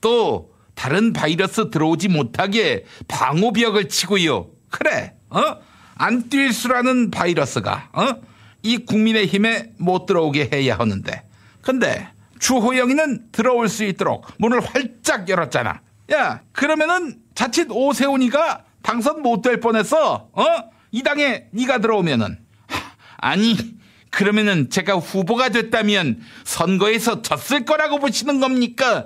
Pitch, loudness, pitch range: 225 Hz, -19 LUFS, 195-255 Hz